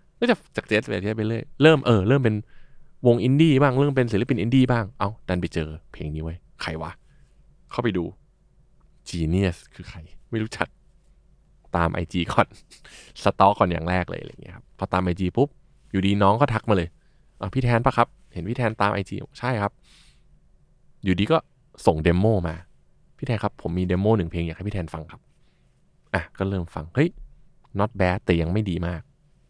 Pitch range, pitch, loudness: 90-130 Hz, 100 Hz, -23 LUFS